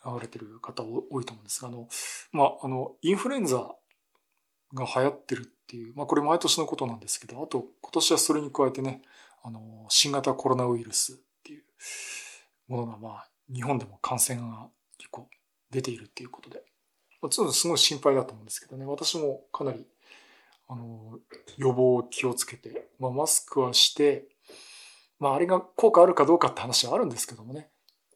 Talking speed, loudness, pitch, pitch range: 365 characters per minute, -26 LUFS, 130 Hz, 120-155 Hz